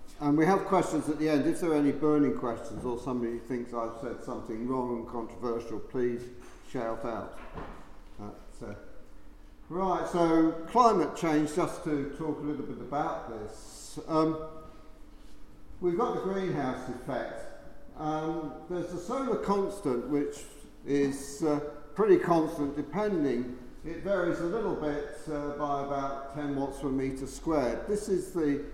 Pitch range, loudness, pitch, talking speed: 125-160 Hz, -31 LUFS, 145 Hz, 150 wpm